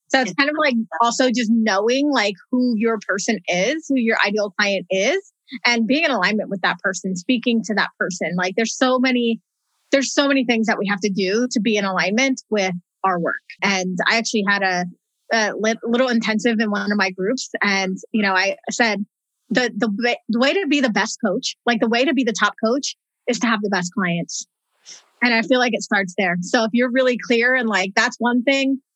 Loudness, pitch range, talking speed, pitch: -19 LUFS, 200-250 Hz, 220 wpm, 225 Hz